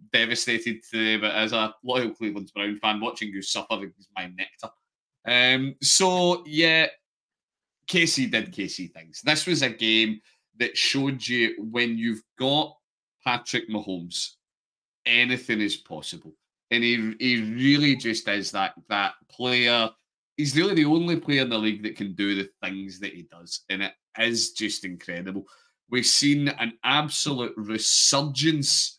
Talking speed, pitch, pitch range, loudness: 150 wpm, 115 Hz, 105-140 Hz, -23 LUFS